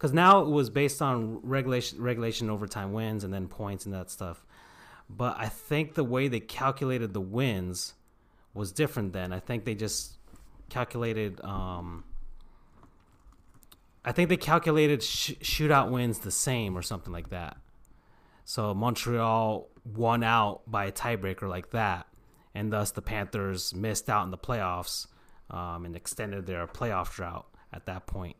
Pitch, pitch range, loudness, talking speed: 105 Hz, 90-120 Hz, -30 LUFS, 155 wpm